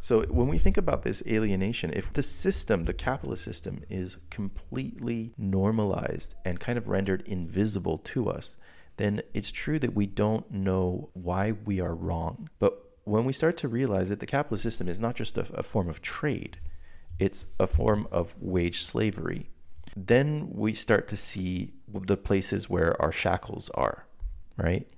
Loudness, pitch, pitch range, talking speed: -29 LUFS, 95 Hz, 85-110 Hz, 170 wpm